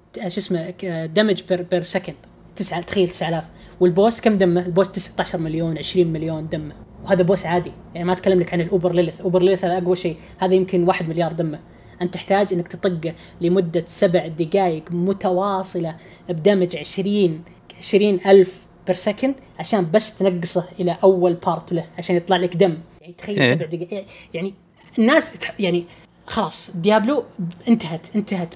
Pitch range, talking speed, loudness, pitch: 175-195 Hz, 160 wpm, -20 LUFS, 180 Hz